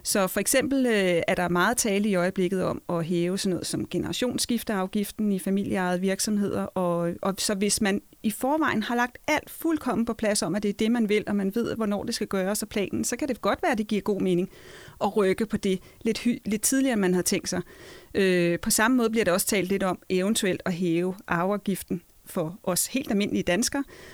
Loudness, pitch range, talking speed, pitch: -26 LUFS, 185-225 Hz, 225 wpm, 205 Hz